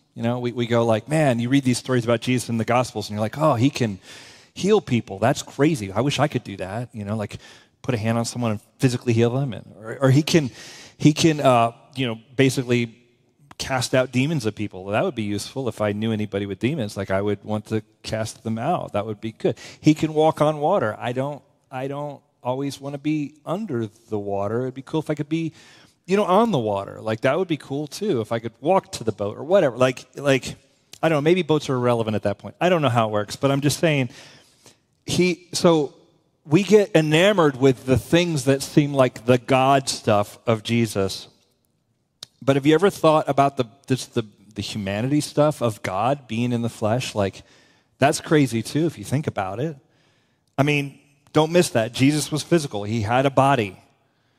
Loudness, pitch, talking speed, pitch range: -22 LUFS, 130 Hz, 225 wpm, 115-150 Hz